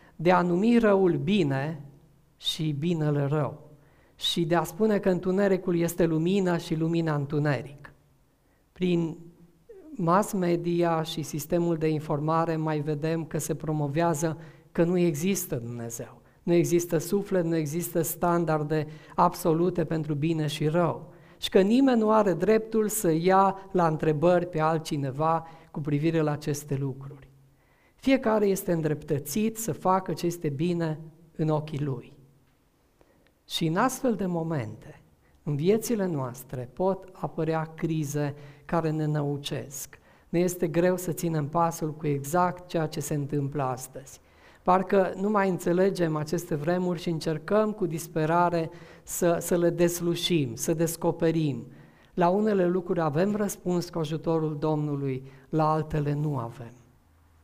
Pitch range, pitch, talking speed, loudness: 150-175 Hz, 165 Hz, 135 wpm, -27 LUFS